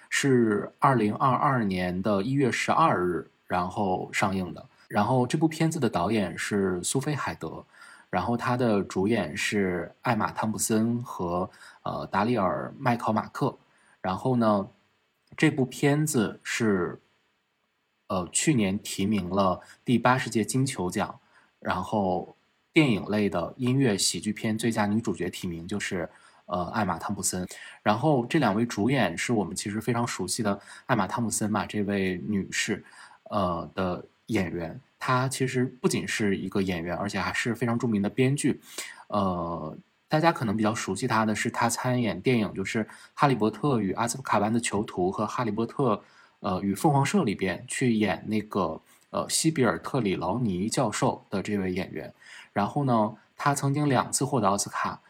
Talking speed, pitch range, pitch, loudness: 245 characters per minute, 100-130 Hz, 110 Hz, -27 LUFS